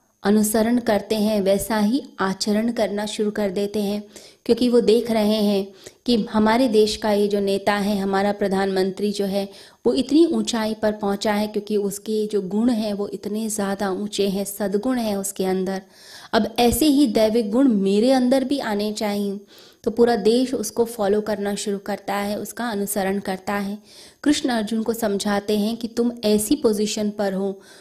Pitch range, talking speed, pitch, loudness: 200-225 Hz, 175 wpm, 210 Hz, -21 LUFS